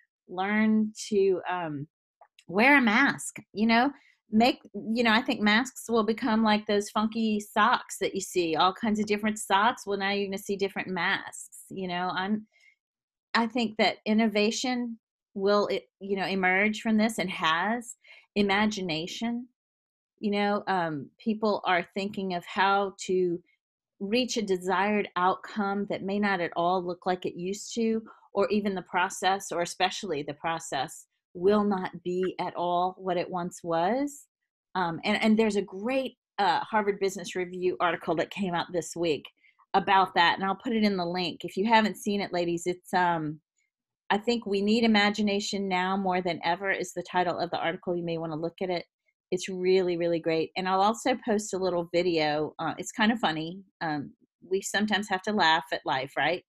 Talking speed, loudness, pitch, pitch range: 185 wpm, -28 LUFS, 195 Hz, 180-215 Hz